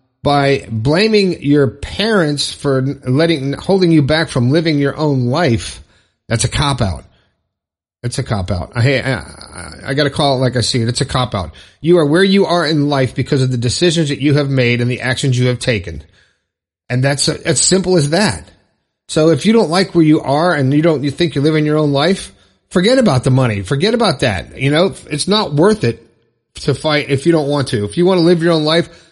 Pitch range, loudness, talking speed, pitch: 120-165 Hz, -14 LUFS, 230 wpm, 140 Hz